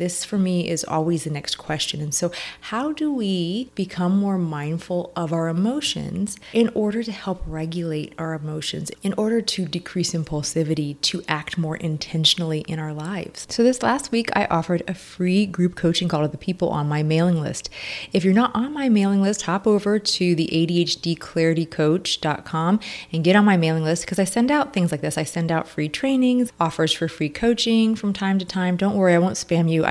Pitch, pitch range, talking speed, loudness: 175 Hz, 160-200 Hz, 200 wpm, -22 LUFS